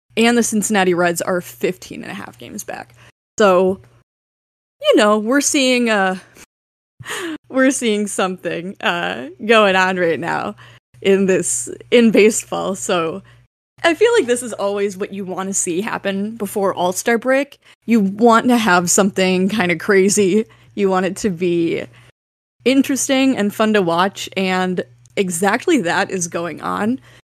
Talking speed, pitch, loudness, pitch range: 155 wpm, 200 Hz, -17 LUFS, 185-235 Hz